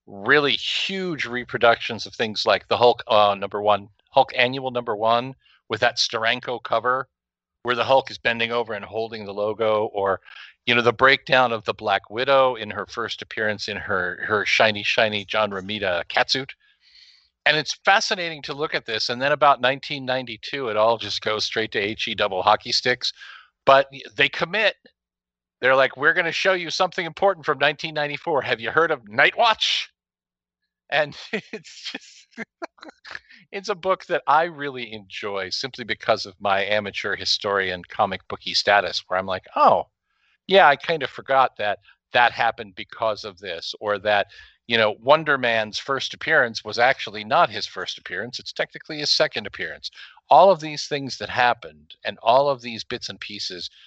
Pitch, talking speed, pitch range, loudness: 120 Hz, 175 wpm, 105-145 Hz, -21 LUFS